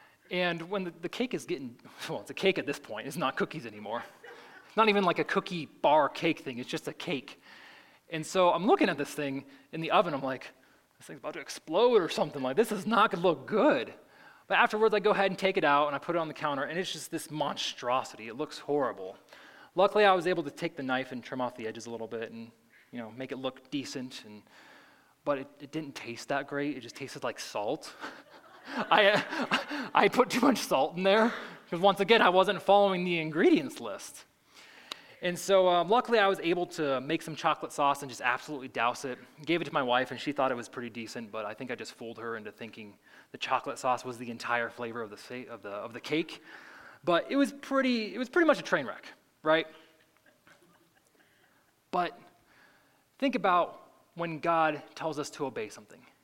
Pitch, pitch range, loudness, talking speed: 155 Hz, 130-195 Hz, -30 LUFS, 225 wpm